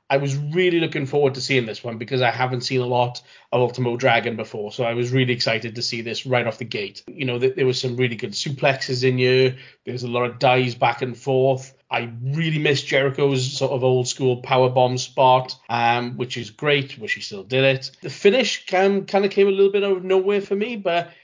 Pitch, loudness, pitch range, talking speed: 130 Hz, -21 LUFS, 125-145 Hz, 235 wpm